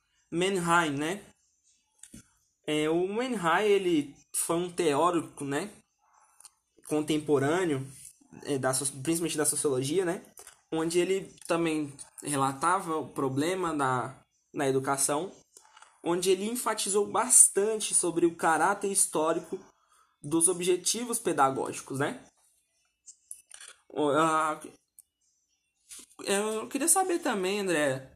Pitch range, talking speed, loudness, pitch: 145-195 Hz, 95 wpm, -27 LUFS, 165 Hz